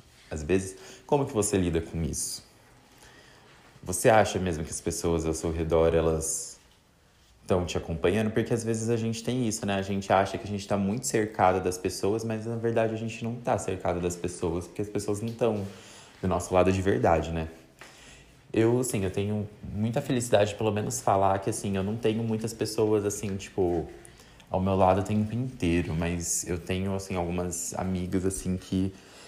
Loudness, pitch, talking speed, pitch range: -28 LUFS, 95 Hz, 195 wpm, 90-110 Hz